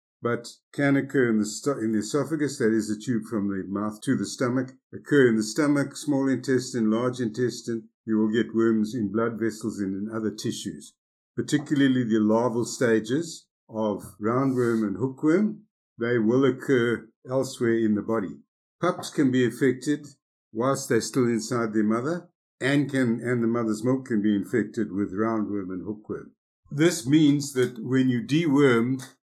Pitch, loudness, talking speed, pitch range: 120 Hz, -25 LUFS, 165 wpm, 110-135 Hz